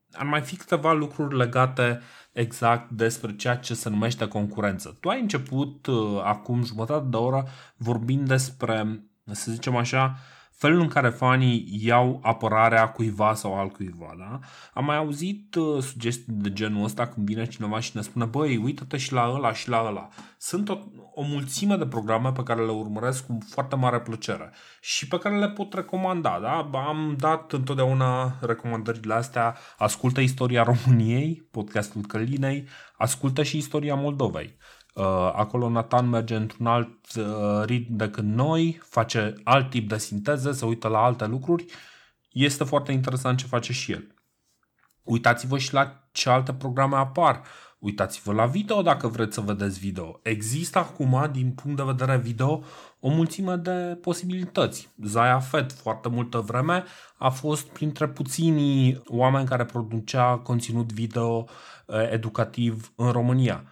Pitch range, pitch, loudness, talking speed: 115-140 Hz, 125 Hz, -25 LUFS, 150 wpm